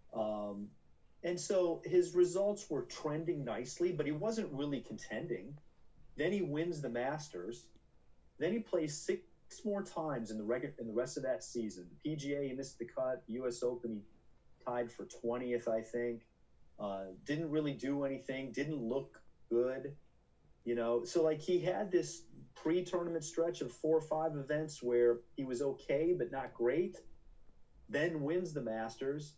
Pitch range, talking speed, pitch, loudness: 120-165 Hz, 165 wpm, 140 Hz, -38 LUFS